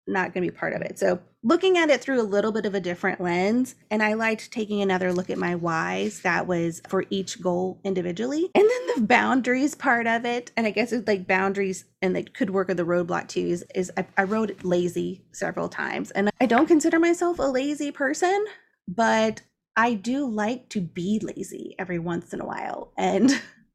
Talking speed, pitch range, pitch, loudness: 215 wpm, 185-250 Hz, 215 Hz, -24 LUFS